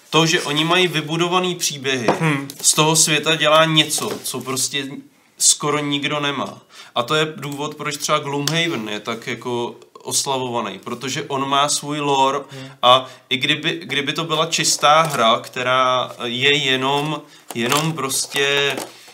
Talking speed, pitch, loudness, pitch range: 140 wpm, 145 Hz, -18 LUFS, 130-155 Hz